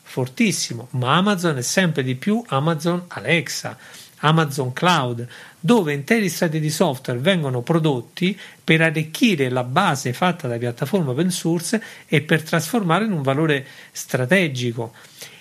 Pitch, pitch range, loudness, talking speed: 160 Hz, 135-180 Hz, -20 LUFS, 130 wpm